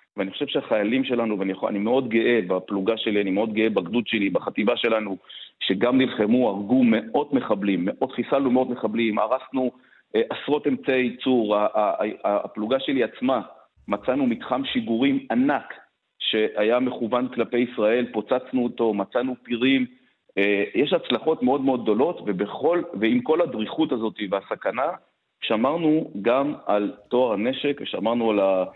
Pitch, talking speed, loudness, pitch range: 120 Hz, 150 wpm, -23 LUFS, 110-130 Hz